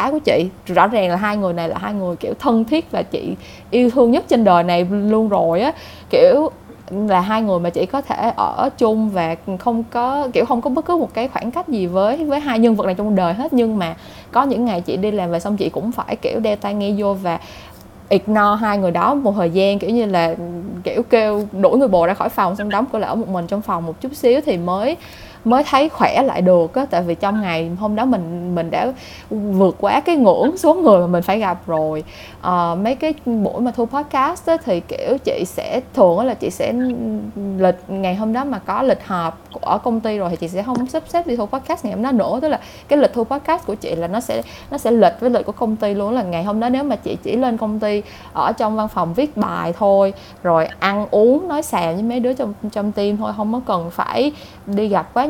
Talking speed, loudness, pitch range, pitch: 250 wpm, -18 LUFS, 185-255 Hz, 215 Hz